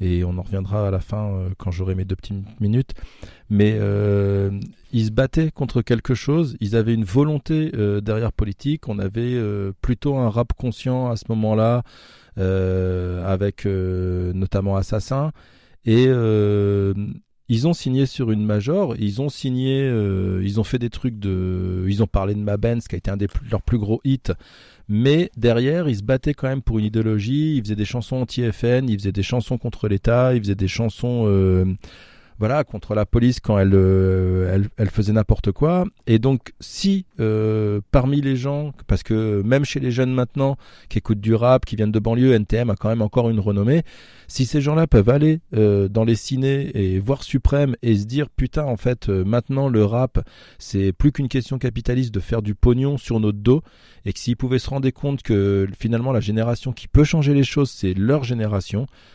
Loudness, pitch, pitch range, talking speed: -21 LUFS, 115 Hz, 100-130 Hz, 200 wpm